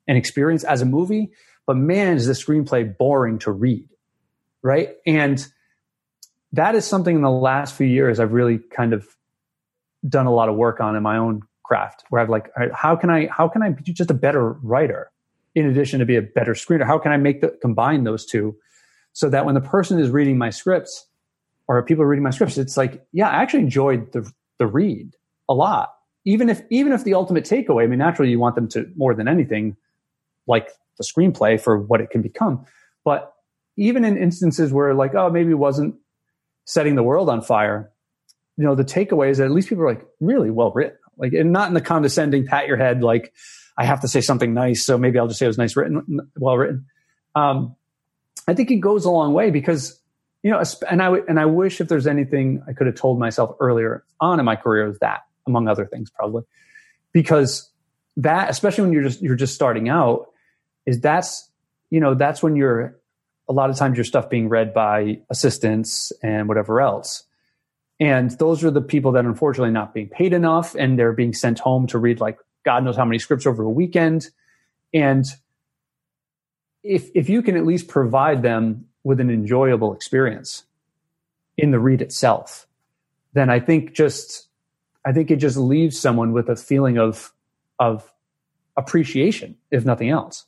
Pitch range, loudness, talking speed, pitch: 120-160 Hz, -19 LUFS, 200 wpm, 140 Hz